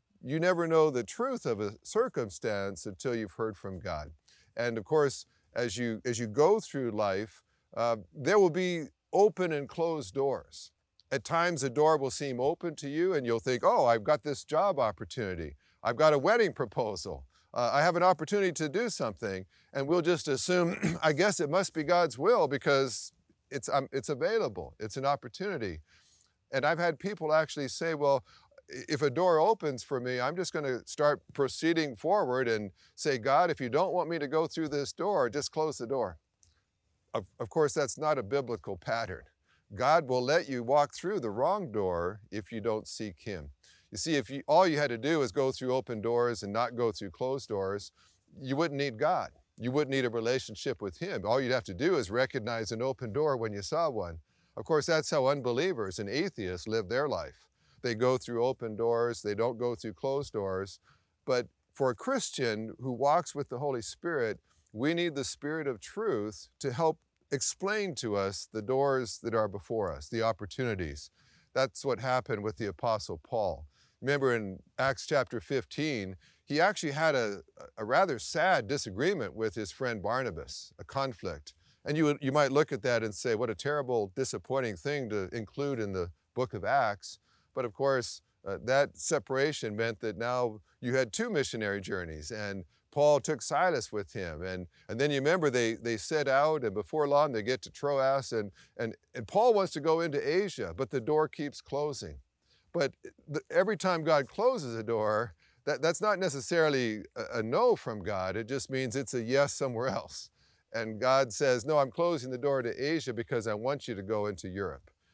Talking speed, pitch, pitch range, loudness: 195 wpm, 125 Hz, 105-150 Hz, -31 LUFS